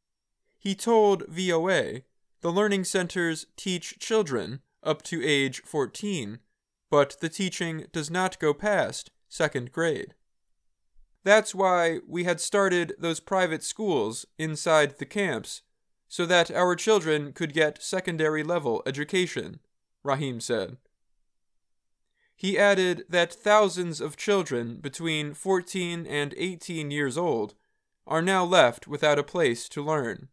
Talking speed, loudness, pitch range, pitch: 125 wpm, -26 LUFS, 150-185 Hz, 170 Hz